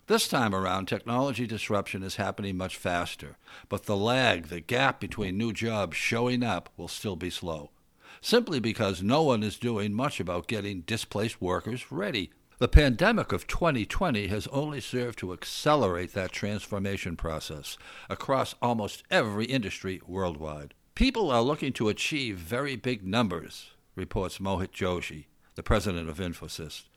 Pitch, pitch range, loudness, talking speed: 100 Hz, 90-120 Hz, -29 LUFS, 150 wpm